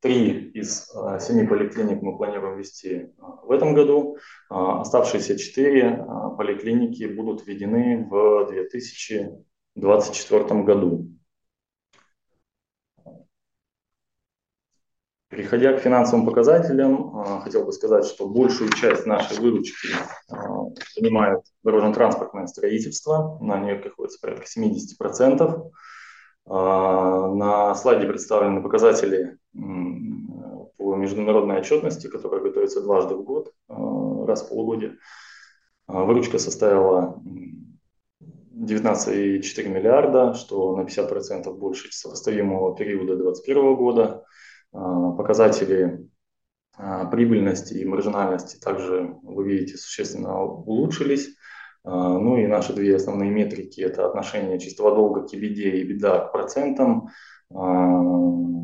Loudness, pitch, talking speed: -22 LUFS, 105 Hz, 95 wpm